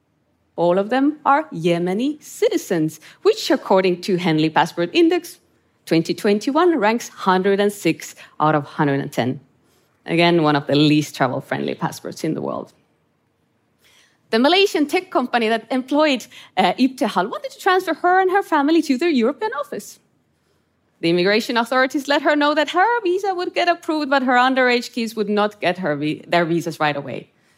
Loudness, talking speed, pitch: -19 LUFS, 155 wpm, 230 Hz